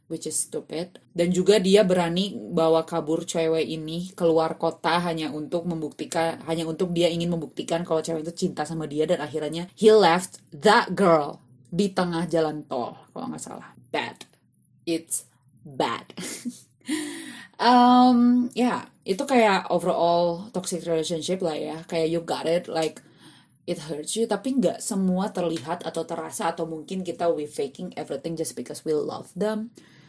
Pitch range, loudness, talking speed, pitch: 160-190 Hz, -24 LUFS, 155 wpm, 170 Hz